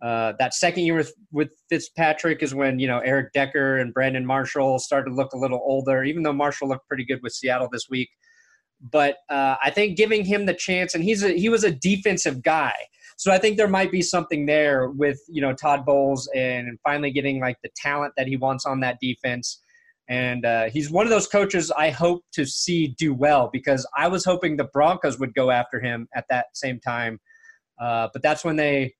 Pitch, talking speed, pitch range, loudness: 145 Hz, 215 wpm, 130-170 Hz, -22 LUFS